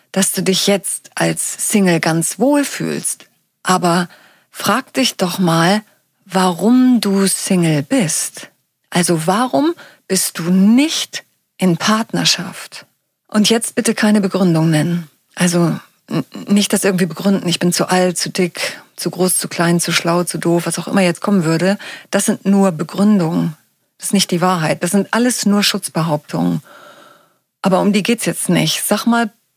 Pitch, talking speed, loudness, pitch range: 190 Hz, 160 wpm, -15 LUFS, 170-205 Hz